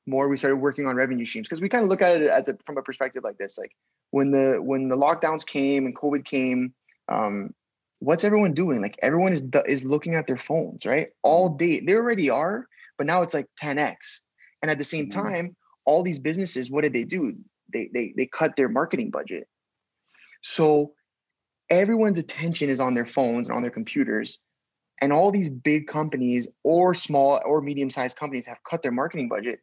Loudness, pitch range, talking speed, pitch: -24 LUFS, 135-170 Hz, 205 wpm, 150 Hz